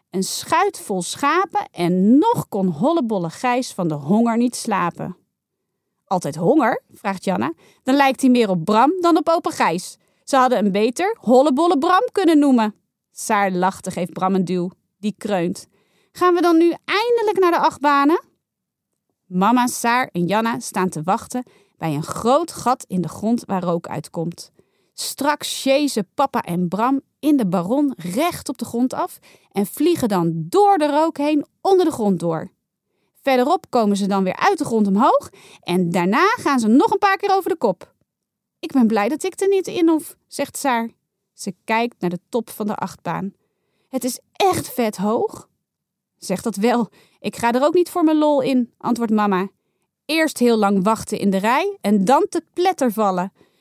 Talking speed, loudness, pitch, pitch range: 180 wpm, -19 LUFS, 235 Hz, 195-300 Hz